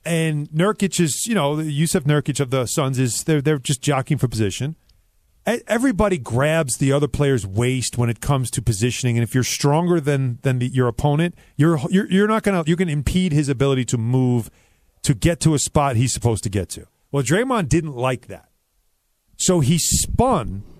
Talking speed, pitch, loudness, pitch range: 200 wpm, 140 Hz, -20 LUFS, 120-165 Hz